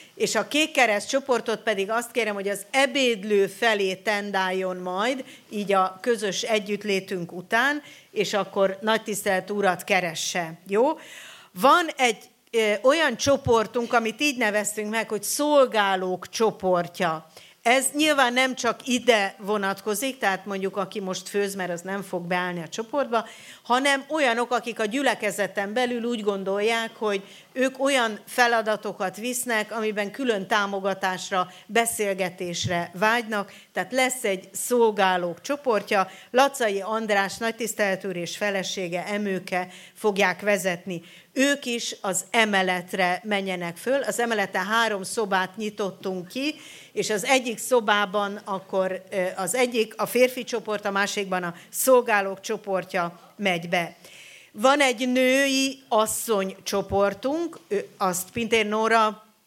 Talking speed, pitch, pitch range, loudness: 125 wpm, 210 Hz, 190-235 Hz, -24 LUFS